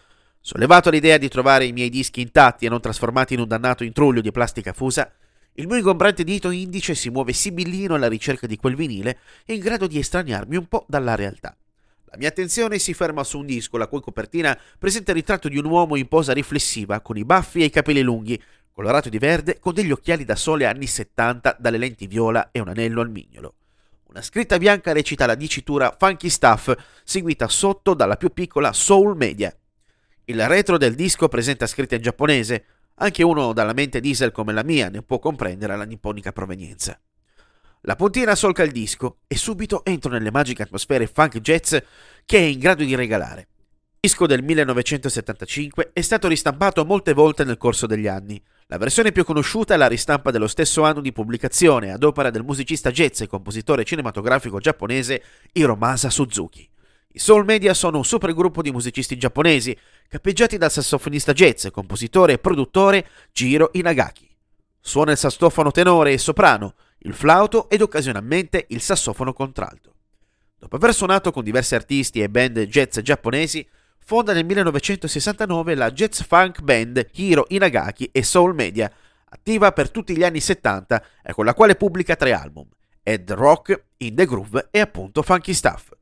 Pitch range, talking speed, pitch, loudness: 115-175 Hz, 175 wpm, 140 Hz, -19 LUFS